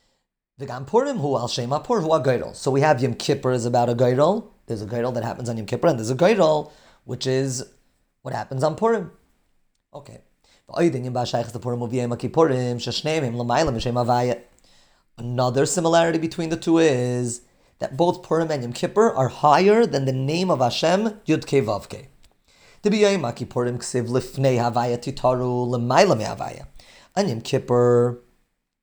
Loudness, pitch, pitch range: -22 LUFS, 130 Hz, 120-160 Hz